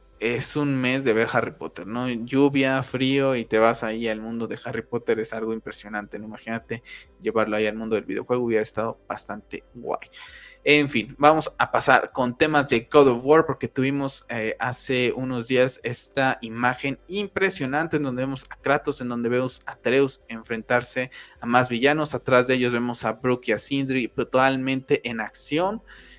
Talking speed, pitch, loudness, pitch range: 185 wpm, 125 Hz, -24 LUFS, 115-135 Hz